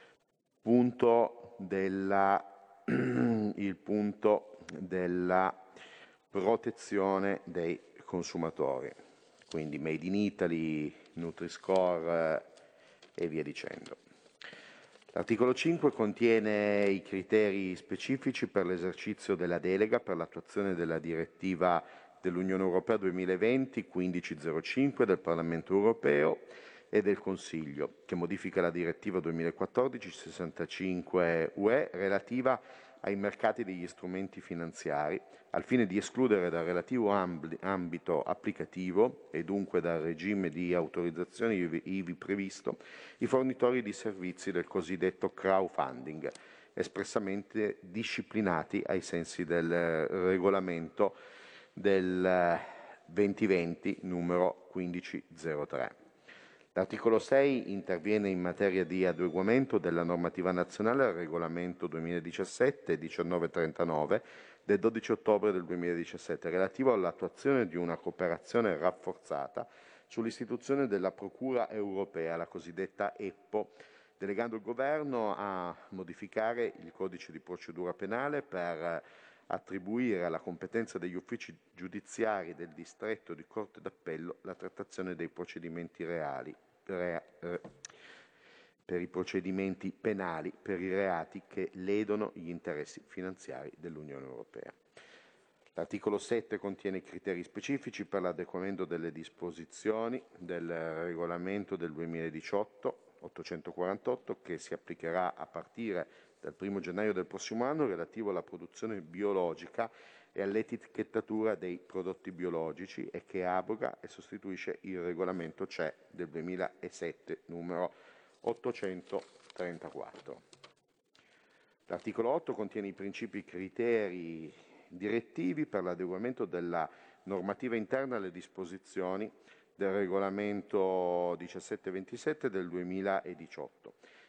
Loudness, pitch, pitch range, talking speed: -35 LUFS, 95 Hz, 85-105 Hz, 100 wpm